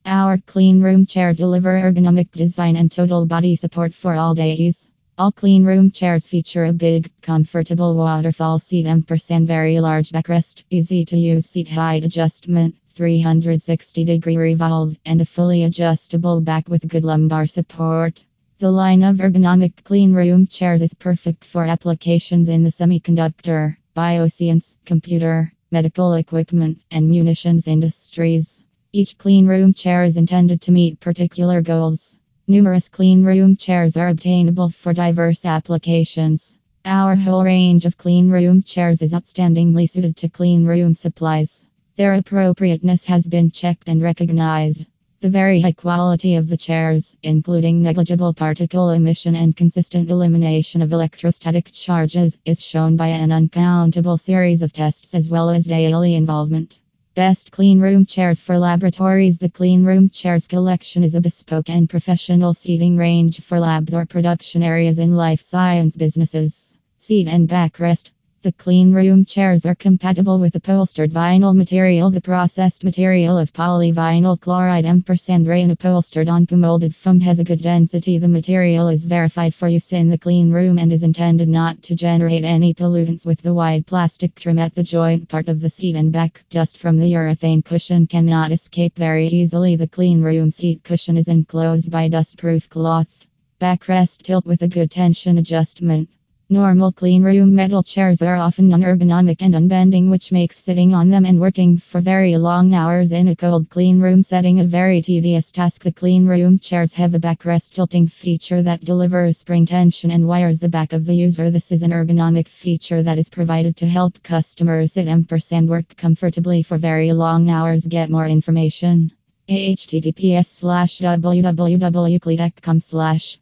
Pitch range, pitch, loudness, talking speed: 165-180 Hz, 170 Hz, -16 LUFS, 160 wpm